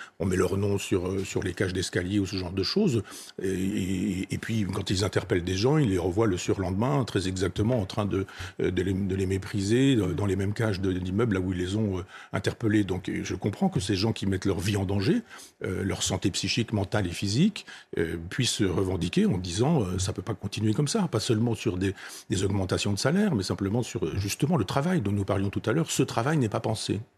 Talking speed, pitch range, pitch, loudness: 240 wpm, 95-115 Hz, 100 Hz, -27 LUFS